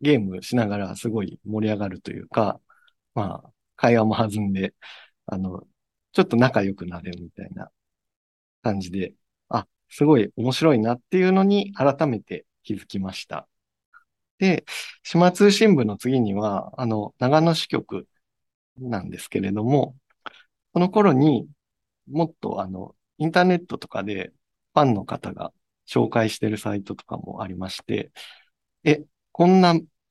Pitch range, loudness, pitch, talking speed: 100-160 Hz, -22 LUFS, 120 Hz, 275 characters per minute